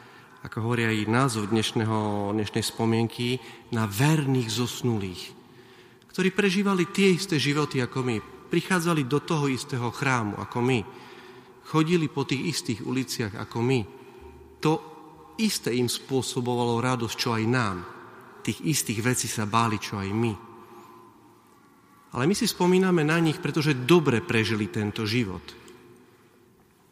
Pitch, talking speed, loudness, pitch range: 125 Hz, 125 wpm, -26 LUFS, 115-150 Hz